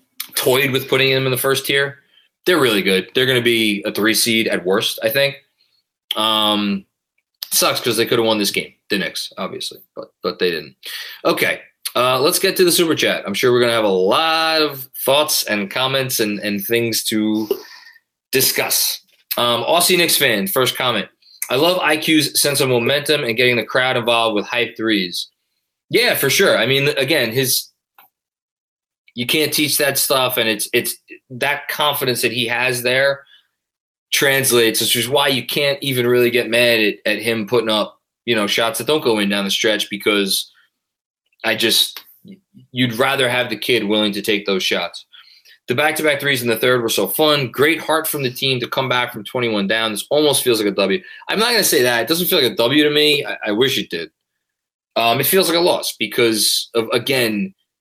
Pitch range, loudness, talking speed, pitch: 110-145 Hz, -16 LUFS, 200 wpm, 125 Hz